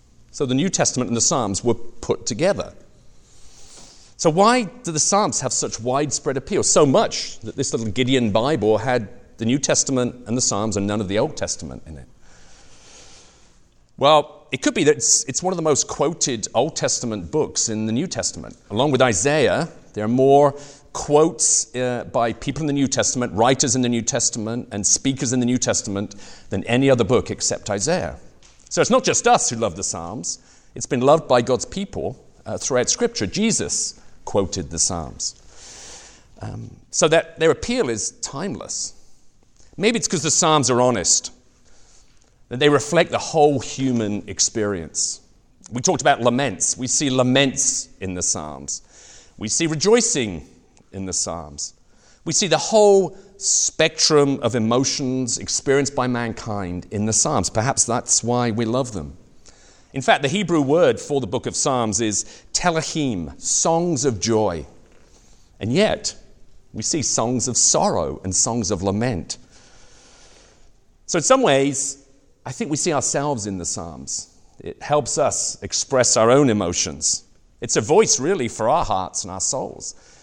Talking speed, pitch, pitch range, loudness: 170 wpm, 125 Hz, 110-150 Hz, -20 LUFS